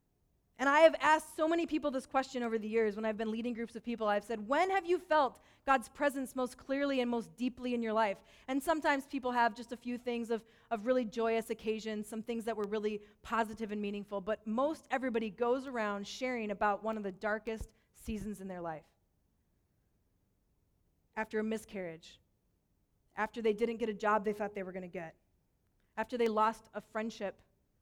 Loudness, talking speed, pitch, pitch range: -35 LUFS, 200 wpm, 225 Hz, 210-250 Hz